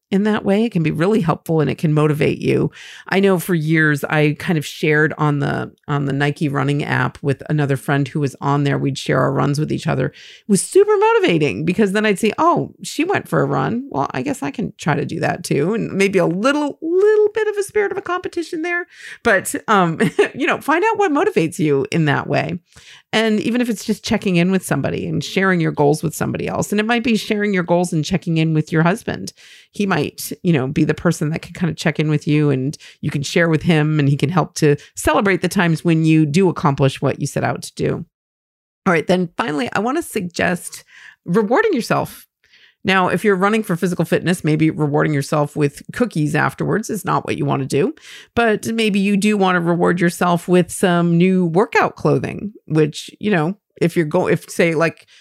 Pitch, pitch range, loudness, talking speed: 175 Hz, 150-210 Hz, -18 LUFS, 230 wpm